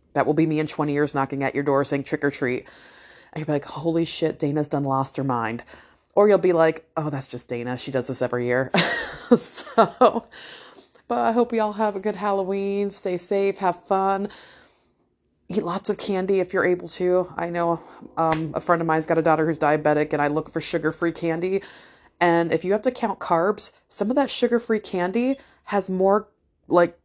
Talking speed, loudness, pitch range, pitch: 210 wpm, -23 LUFS, 150-195 Hz, 170 Hz